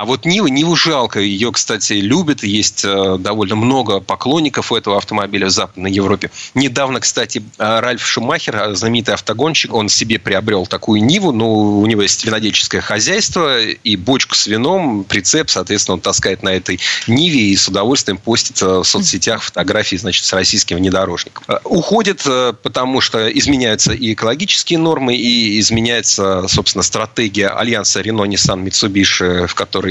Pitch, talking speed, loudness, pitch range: 105 Hz, 150 wpm, -13 LUFS, 100-120 Hz